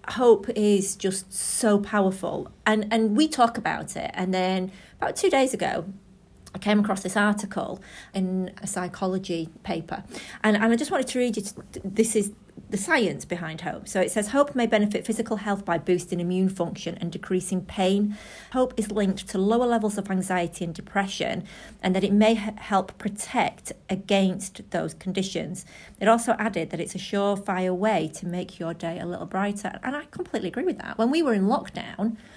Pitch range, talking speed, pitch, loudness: 185-225 Hz, 190 wpm, 200 Hz, -26 LUFS